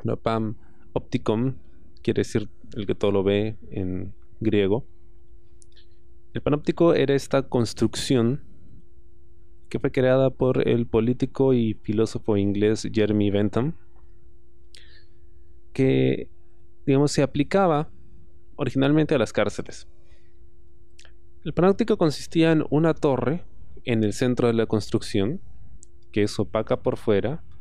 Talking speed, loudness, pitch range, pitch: 115 wpm, -24 LUFS, 85-130 Hz, 110 Hz